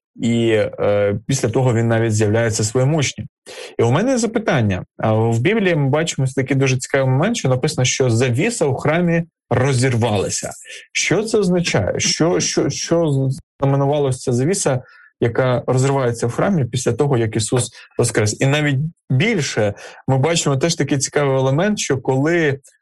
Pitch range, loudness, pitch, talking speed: 120-155 Hz, -18 LUFS, 135 Hz, 150 wpm